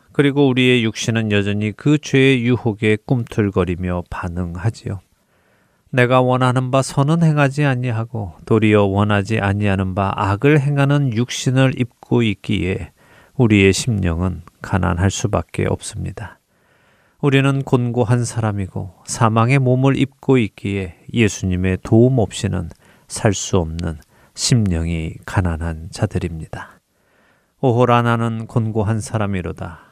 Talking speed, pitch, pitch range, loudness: 280 characters per minute, 110 Hz, 95-125 Hz, -18 LUFS